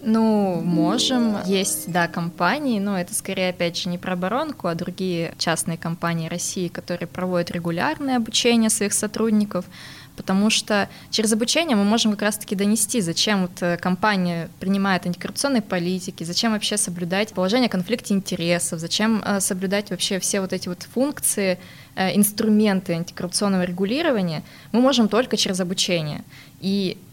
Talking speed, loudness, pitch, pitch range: 135 wpm, -22 LUFS, 195 Hz, 175-215 Hz